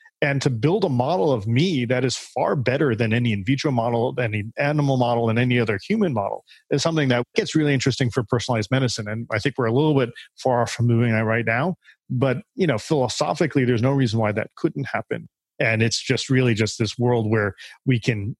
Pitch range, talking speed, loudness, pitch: 115-140 Hz, 220 wpm, -22 LUFS, 125 Hz